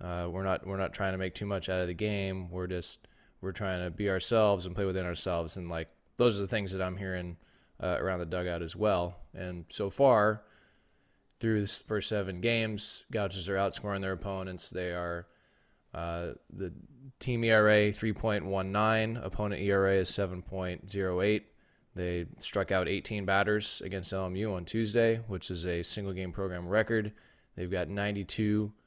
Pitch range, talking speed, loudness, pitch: 90-105 Hz, 185 wpm, -31 LUFS, 95 Hz